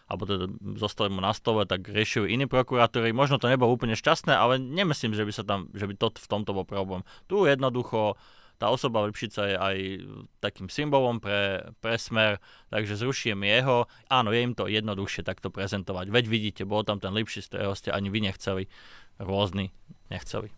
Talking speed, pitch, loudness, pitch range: 185 wpm, 105 Hz, -27 LUFS, 100-120 Hz